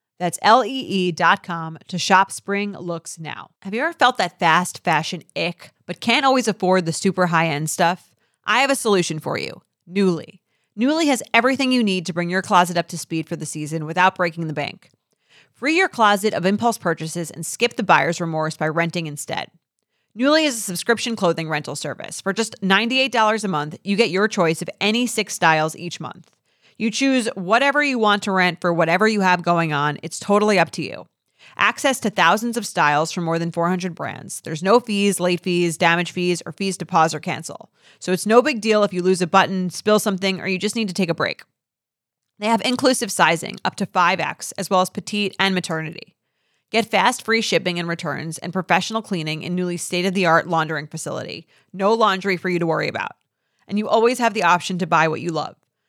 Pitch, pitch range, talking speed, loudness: 180 Hz, 165-210 Hz, 210 wpm, -20 LUFS